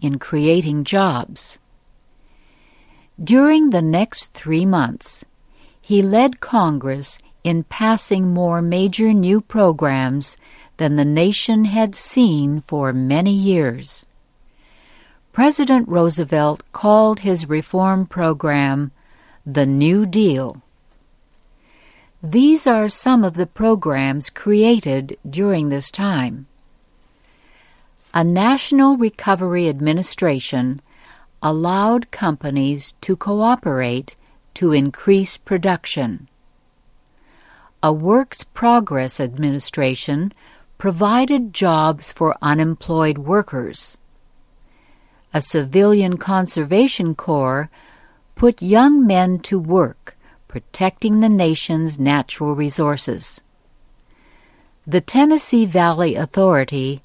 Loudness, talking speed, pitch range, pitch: -17 LUFS, 85 wpm, 150-205 Hz, 175 Hz